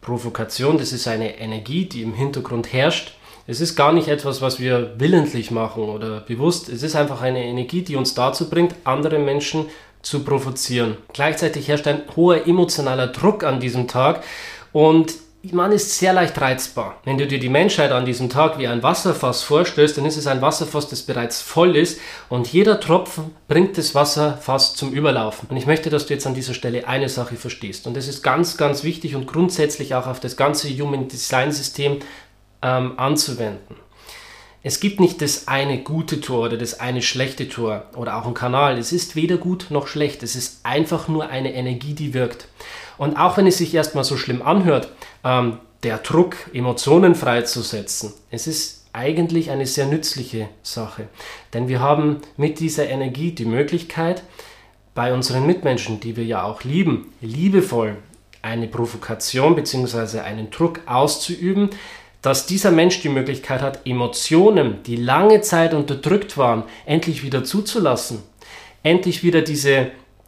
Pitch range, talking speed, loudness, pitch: 120-160 Hz, 170 wpm, -19 LUFS, 135 Hz